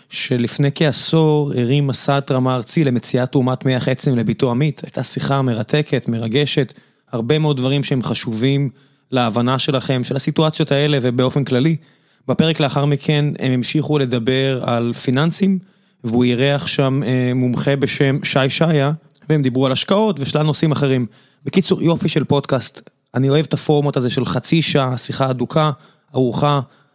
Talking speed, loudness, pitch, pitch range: 145 wpm, -18 LUFS, 140 Hz, 130-150 Hz